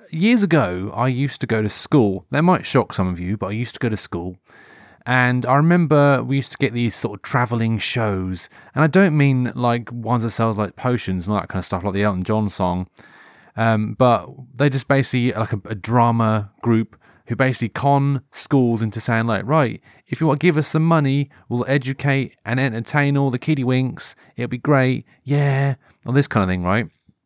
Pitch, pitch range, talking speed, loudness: 120 Hz, 110-140 Hz, 215 wpm, -19 LUFS